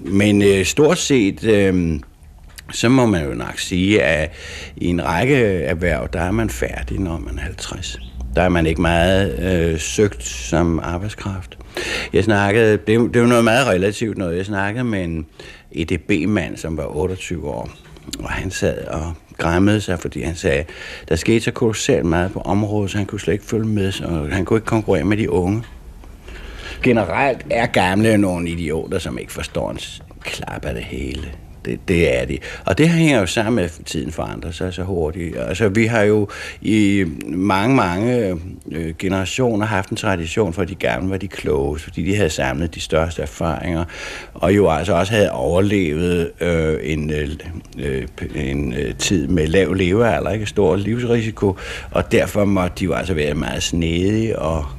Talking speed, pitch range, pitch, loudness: 180 wpm, 80-100 Hz, 90 Hz, -19 LUFS